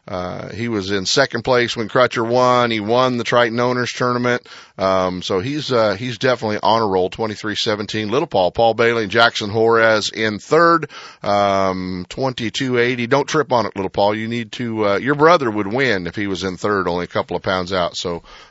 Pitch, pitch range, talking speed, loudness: 115 Hz, 100-125 Hz, 200 wpm, -18 LUFS